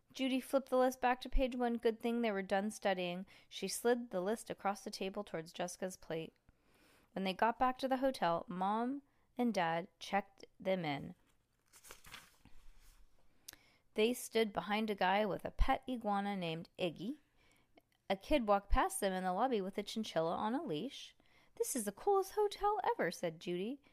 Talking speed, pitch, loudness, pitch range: 175 wpm, 210 Hz, -38 LUFS, 185-255 Hz